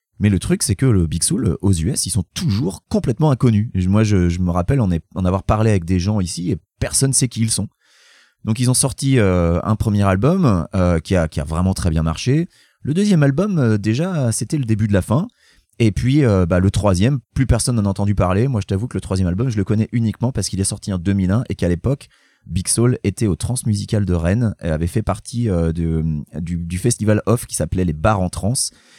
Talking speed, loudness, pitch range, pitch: 245 wpm, -18 LUFS, 90-120 Hz, 105 Hz